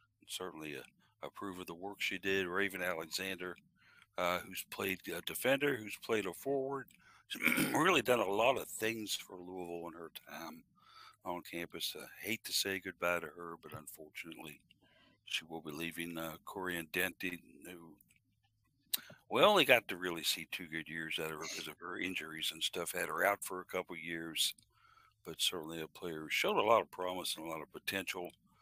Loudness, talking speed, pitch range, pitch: -37 LUFS, 195 wpm, 85-95 Hz, 90 Hz